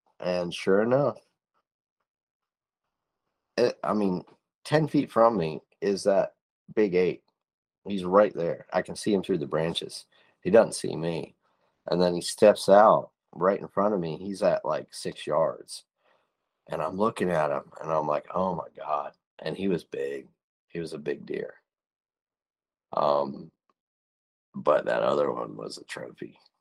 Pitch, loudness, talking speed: 100 Hz, -26 LUFS, 160 wpm